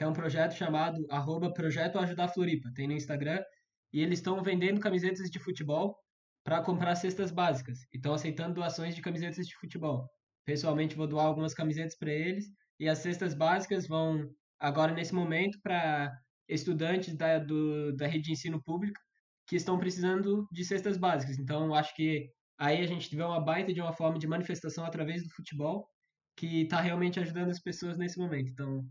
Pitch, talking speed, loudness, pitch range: 165 Hz, 175 wpm, -33 LUFS, 155-180 Hz